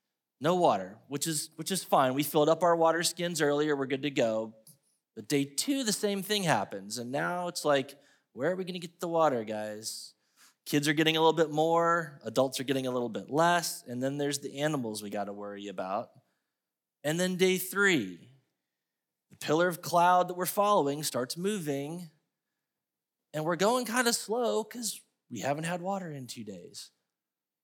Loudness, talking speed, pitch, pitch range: -30 LUFS, 195 wpm, 155 Hz, 140-180 Hz